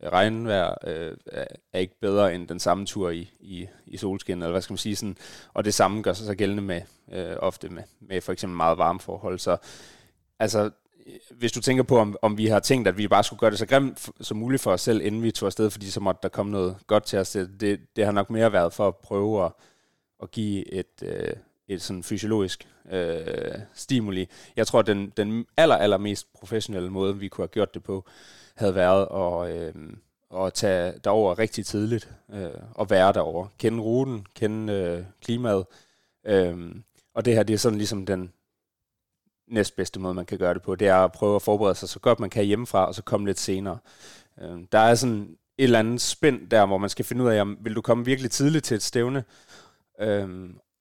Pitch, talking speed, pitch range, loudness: 105 Hz, 220 wpm, 95-115 Hz, -25 LUFS